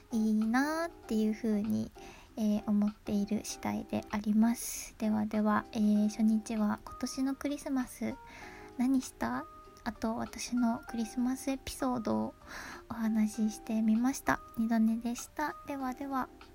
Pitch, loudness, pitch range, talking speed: 230 Hz, -33 LUFS, 215-260 Hz, 265 characters per minute